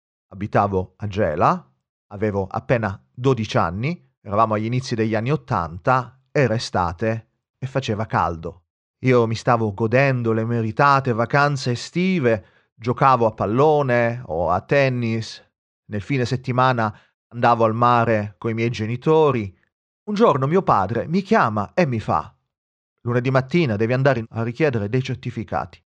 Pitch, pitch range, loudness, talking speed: 120 Hz, 110-130 Hz, -20 LUFS, 135 wpm